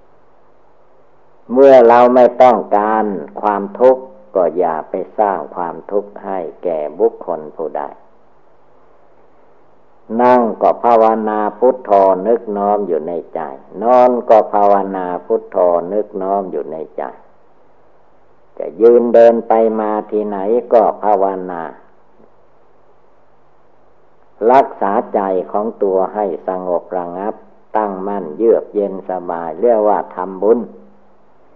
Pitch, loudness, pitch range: 105 Hz, -14 LUFS, 95-120 Hz